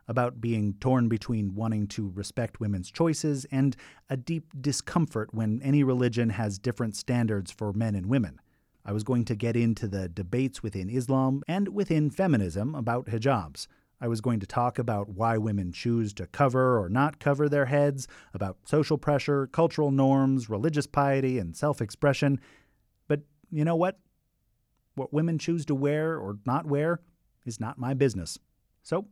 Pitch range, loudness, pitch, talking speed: 110-145 Hz, -28 LUFS, 125 Hz, 165 wpm